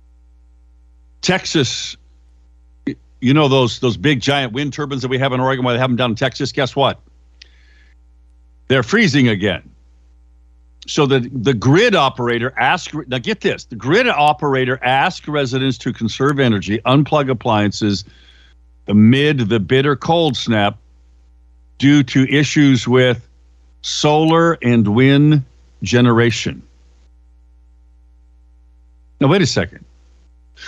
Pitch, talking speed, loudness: 115 Hz, 120 wpm, -15 LUFS